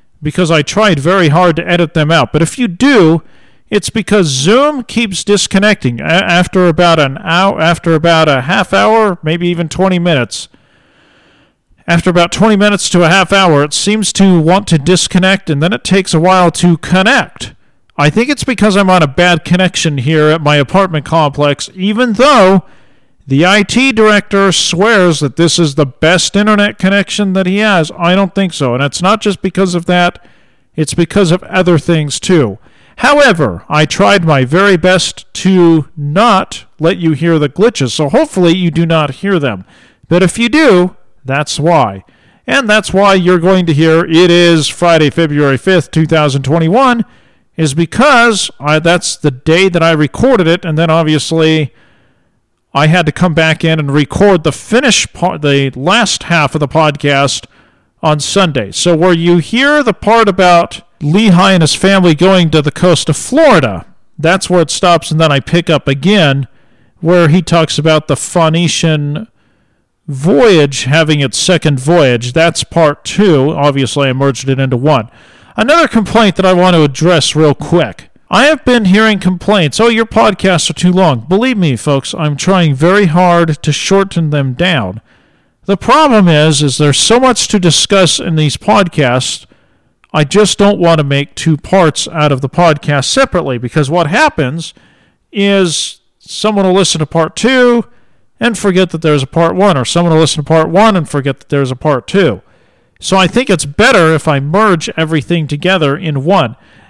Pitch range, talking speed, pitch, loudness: 150-195 Hz, 180 wpm, 170 Hz, -9 LUFS